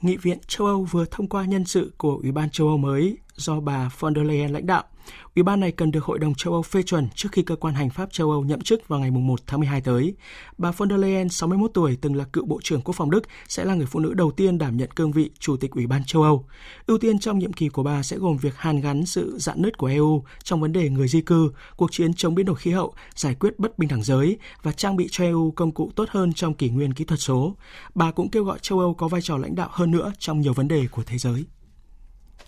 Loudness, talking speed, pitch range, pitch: -23 LUFS, 280 wpm, 145-185 Hz, 160 Hz